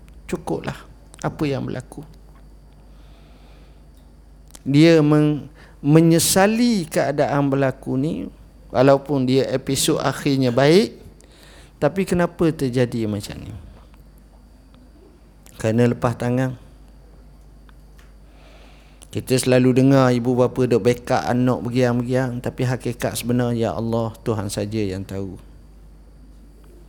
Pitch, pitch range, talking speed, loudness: 125 Hz, 100-135 Hz, 90 wpm, -19 LUFS